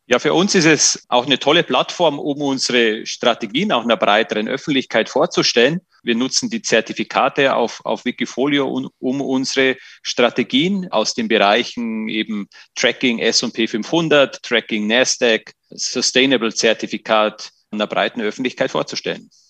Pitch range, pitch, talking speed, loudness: 110-145 Hz, 130 Hz, 130 wpm, -17 LUFS